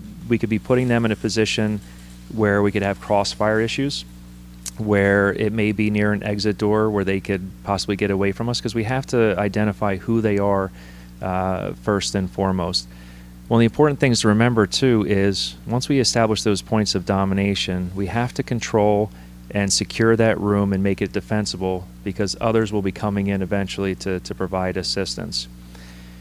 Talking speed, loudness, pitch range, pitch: 190 wpm, -21 LUFS, 95-110 Hz, 100 Hz